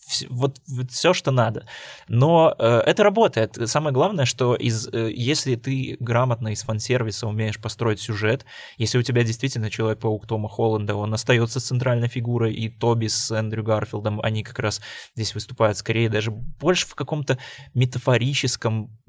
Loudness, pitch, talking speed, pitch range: -22 LUFS, 115 Hz, 155 wpm, 110-130 Hz